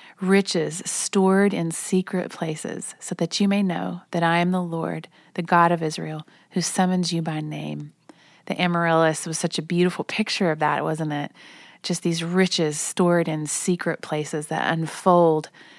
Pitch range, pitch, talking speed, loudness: 160-185 Hz, 170 Hz, 165 wpm, -23 LUFS